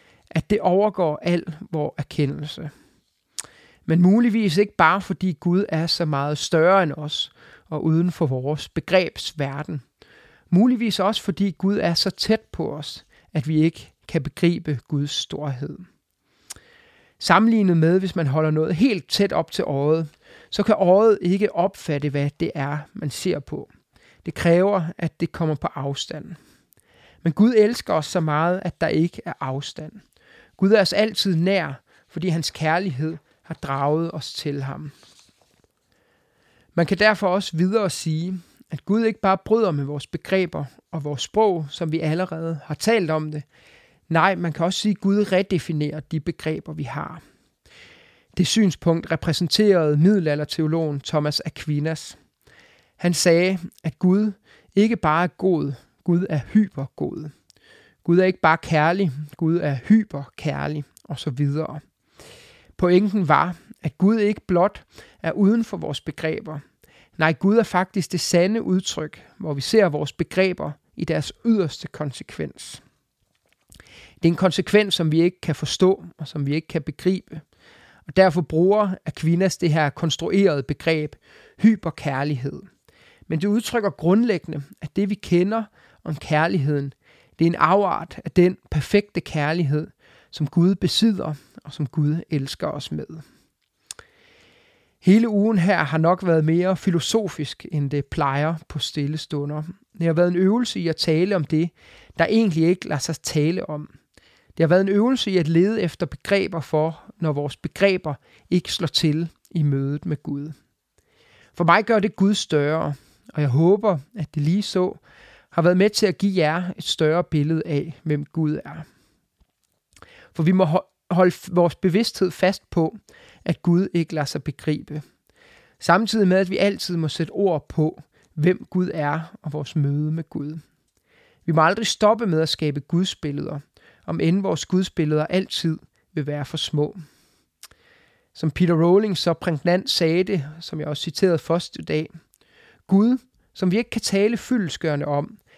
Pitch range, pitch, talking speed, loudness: 150-190 Hz, 170 Hz, 160 wpm, -22 LUFS